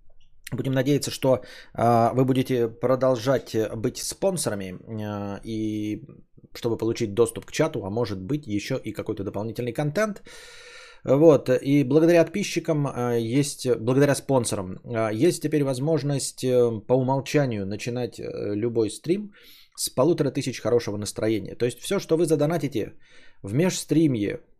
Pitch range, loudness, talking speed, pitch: 110-150 Hz, -24 LUFS, 120 wpm, 125 Hz